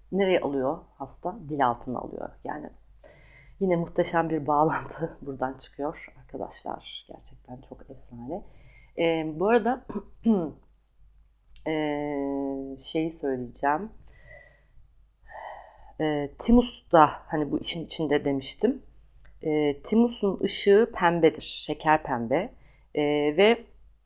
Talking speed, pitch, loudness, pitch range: 95 wpm, 155 Hz, -26 LUFS, 140-180 Hz